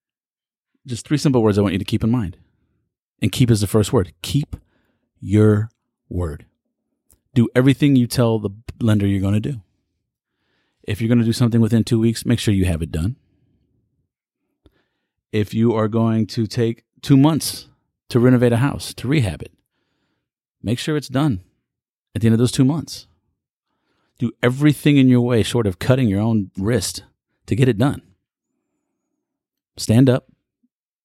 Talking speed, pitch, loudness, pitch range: 170 wpm, 115 Hz, -18 LUFS, 105-130 Hz